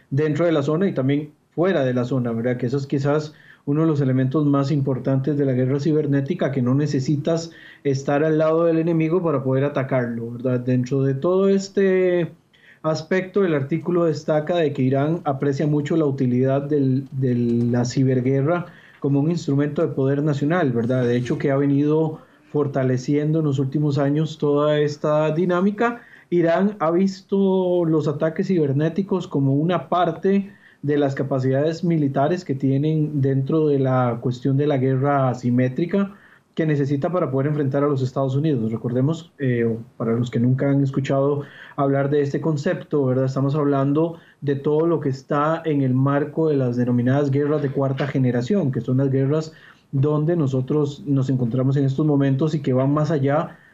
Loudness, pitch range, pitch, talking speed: -21 LUFS, 135-160 Hz, 145 Hz, 170 wpm